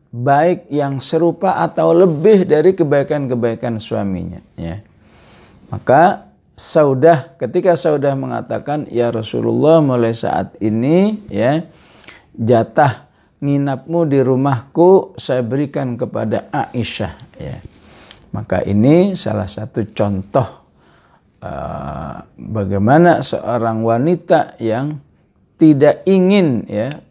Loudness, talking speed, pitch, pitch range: -15 LUFS, 95 wpm, 135 Hz, 115-165 Hz